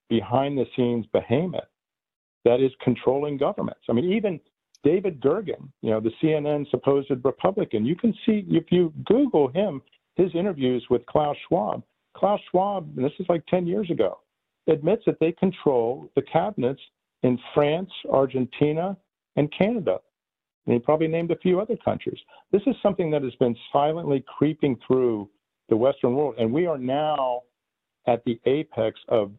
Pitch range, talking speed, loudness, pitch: 125-180 Hz, 160 wpm, -24 LUFS, 150 Hz